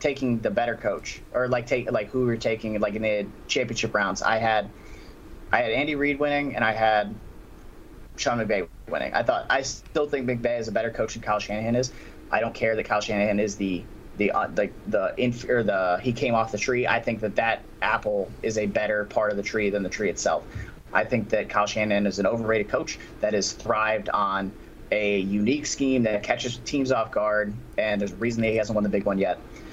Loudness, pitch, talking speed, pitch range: -25 LUFS, 110 Hz, 230 wpm, 105-120 Hz